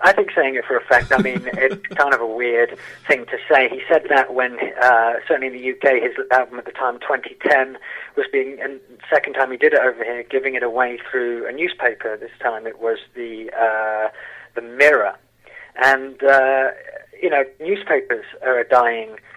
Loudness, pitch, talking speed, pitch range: -18 LUFS, 125 Hz, 205 wpm, 115-135 Hz